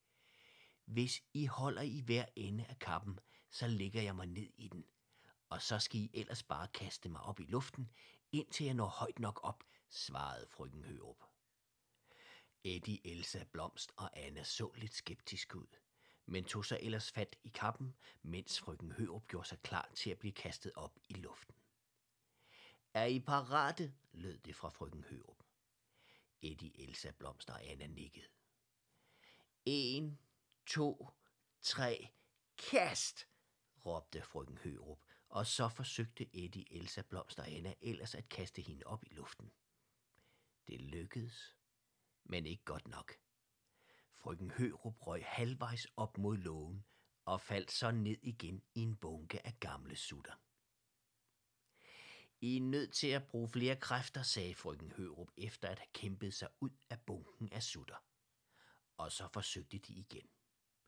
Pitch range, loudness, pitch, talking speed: 95-125 Hz, -44 LUFS, 110 Hz, 150 wpm